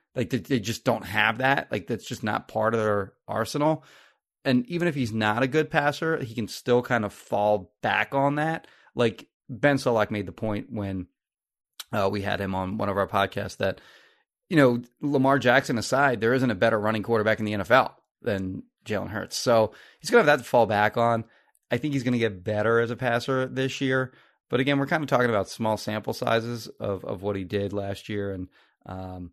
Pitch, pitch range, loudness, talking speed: 115 Hz, 105-130 Hz, -25 LUFS, 215 wpm